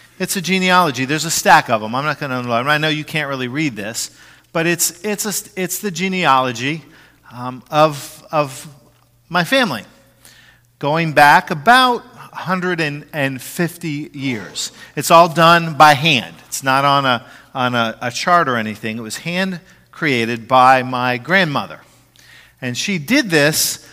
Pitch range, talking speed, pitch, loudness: 130-175 Hz, 155 wpm, 150 Hz, -16 LUFS